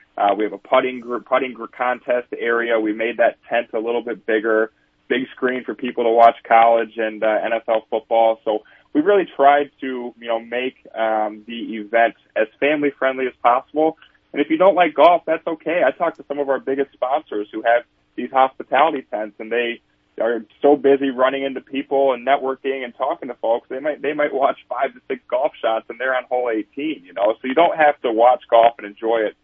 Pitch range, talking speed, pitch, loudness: 115-135 Hz, 220 wpm, 125 Hz, -19 LUFS